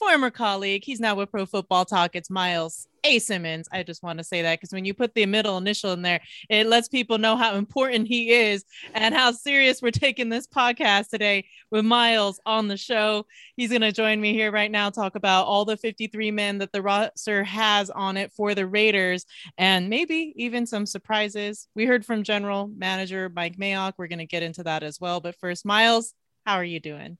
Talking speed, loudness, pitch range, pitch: 215 wpm, -23 LUFS, 190-225 Hz, 205 Hz